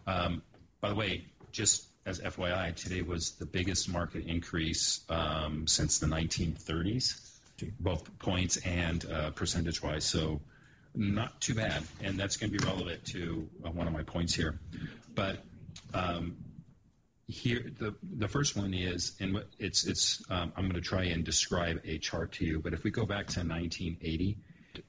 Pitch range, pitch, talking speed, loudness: 80-95 Hz, 85 Hz, 165 wpm, -34 LUFS